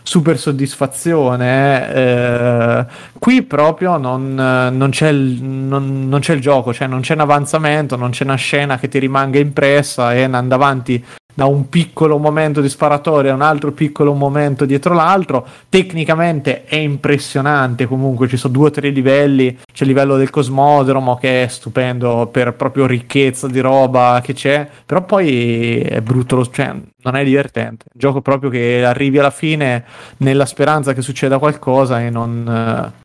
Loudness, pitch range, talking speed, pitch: -14 LUFS, 130-145 Hz, 170 wpm, 135 Hz